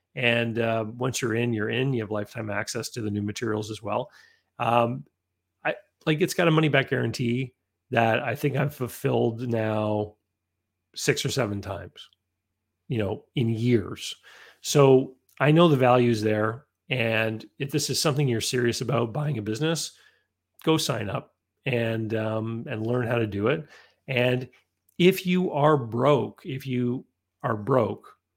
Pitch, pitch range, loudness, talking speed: 120 Hz, 110-135 Hz, -25 LUFS, 165 wpm